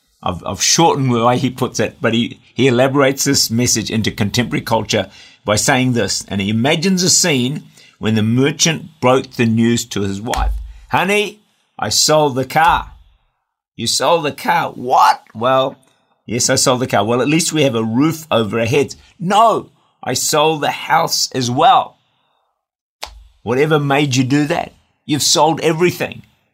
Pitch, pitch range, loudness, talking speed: 130 Hz, 115-150 Hz, -15 LUFS, 170 wpm